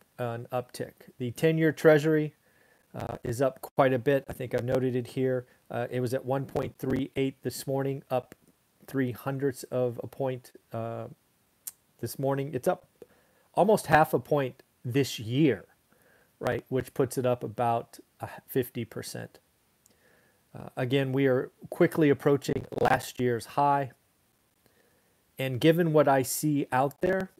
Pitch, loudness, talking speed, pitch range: 130 Hz, -28 LUFS, 140 wpm, 125-140 Hz